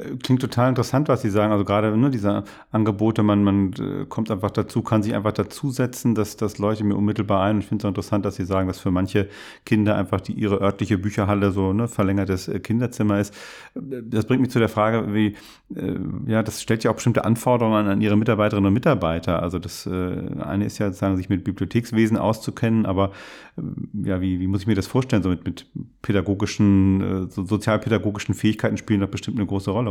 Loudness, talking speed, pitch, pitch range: -22 LUFS, 215 wpm, 105 Hz, 100-115 Hz